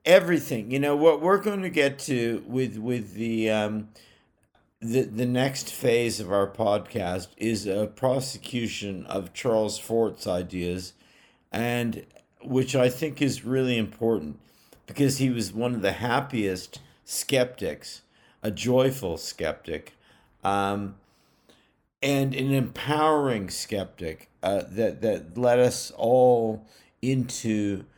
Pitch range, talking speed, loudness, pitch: 105-130 Hz, 120 wpm, -26 LUFS, 115 Hz